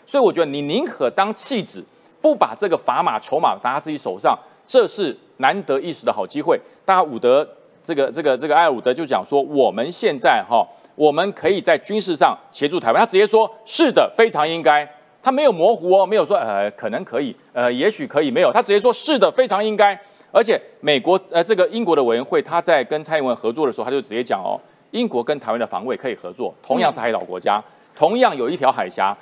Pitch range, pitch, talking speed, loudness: 150-255 Hz, 195 Hz, 340 characters per minute, -19 LUFS